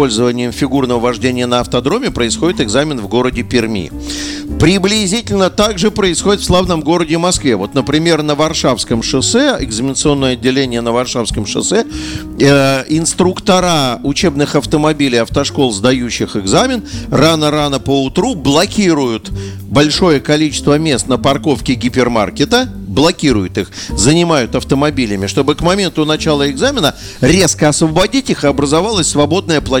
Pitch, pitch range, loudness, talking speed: 140 Hz, 120-160 Hz, -13 LUFS, 120 wpm